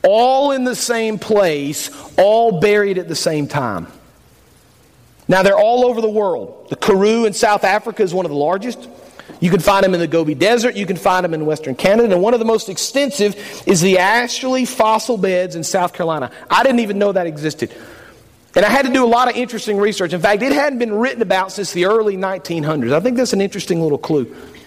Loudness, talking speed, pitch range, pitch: -16 LUFS, 220 wpm, 175-235 Hz, 200 Hz